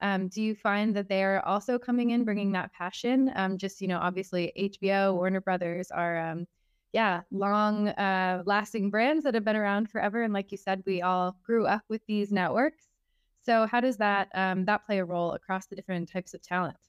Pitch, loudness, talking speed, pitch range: 195 Hz, -29 LUFS, 205 wpm, 185-215 Hz